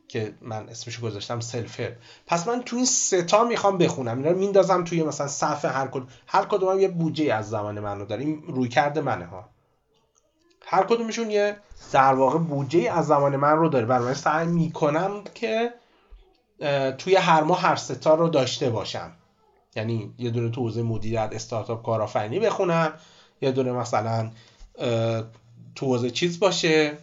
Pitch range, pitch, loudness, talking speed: 115-175 Hz, 145 Hz, -24 LUFS, 165 wpm